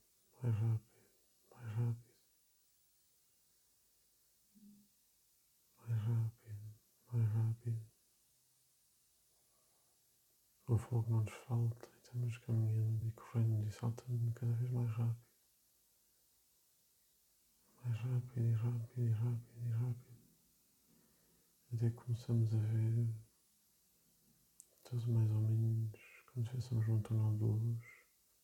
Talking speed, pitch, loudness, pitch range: 95 wpm, 115 Hz, -39 LUFS, 110-120 Hz